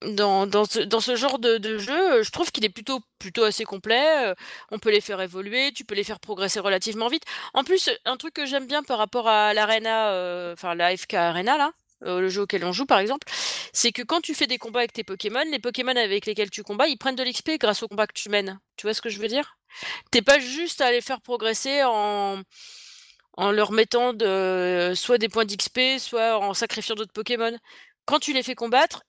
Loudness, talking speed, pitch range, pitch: -23 LUFS, 230 wpm, 205-260 Hz, 225 Hz